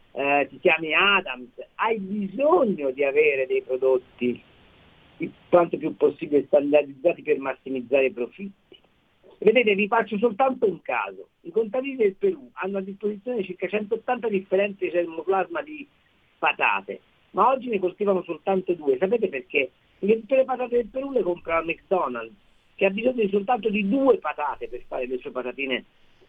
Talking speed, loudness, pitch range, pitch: 155 wpm, -24 LUFS, 165-255 Hz, 200 Hz